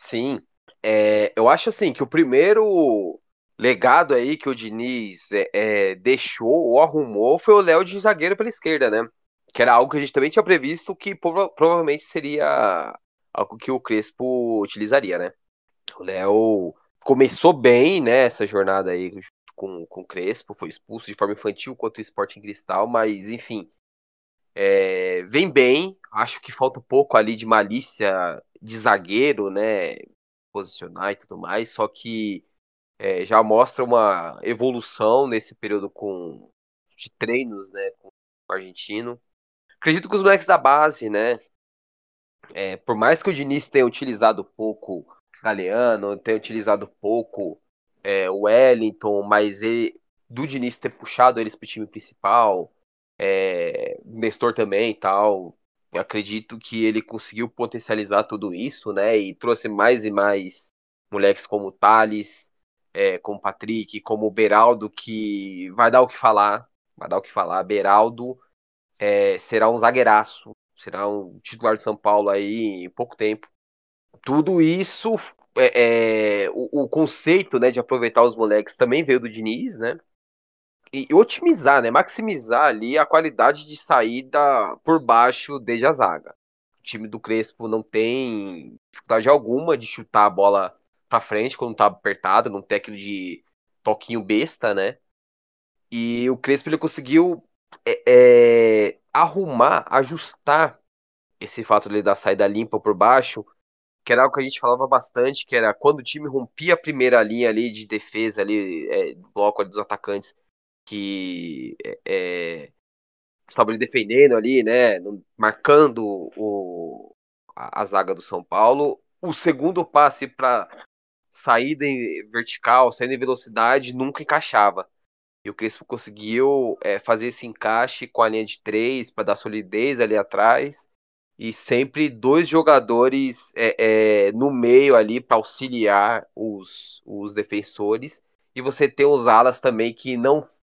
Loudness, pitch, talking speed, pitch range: -20 LUFS, 120 Hz, 150 wpm, 105-160 Hz